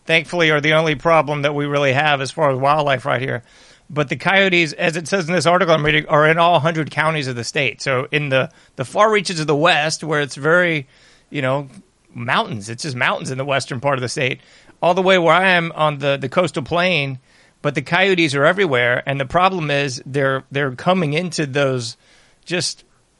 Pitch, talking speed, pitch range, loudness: 150 Hz, 220 wpm, 135-170 Hz, -17 LUFS